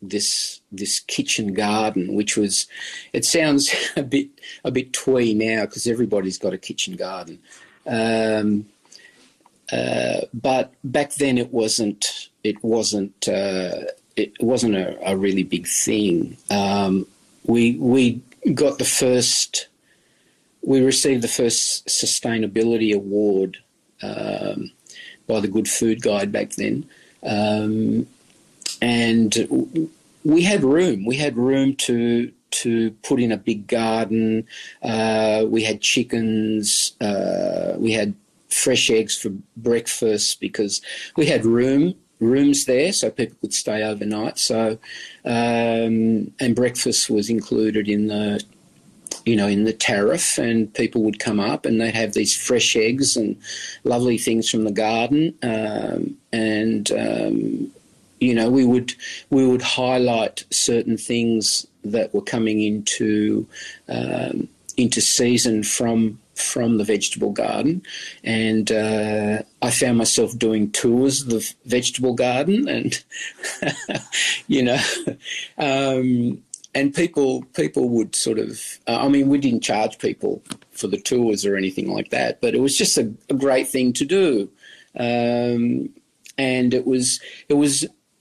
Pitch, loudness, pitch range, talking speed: 115 Hz, -20 LUFS, 110-130 Hz, 135 wpm